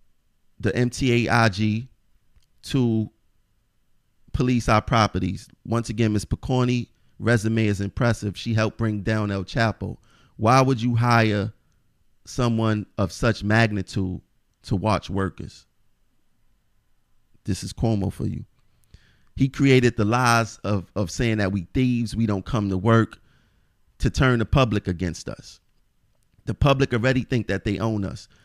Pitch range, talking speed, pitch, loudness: 105-120 Hz, 135 wpm, 110 Hz, -23 LUFS